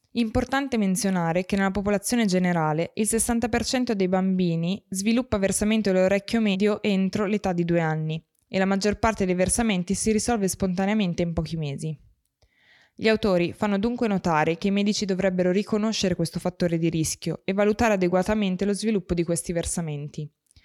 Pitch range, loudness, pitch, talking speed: 175-215 Hz, -24 LUFS, 195 Hz, 155 wpm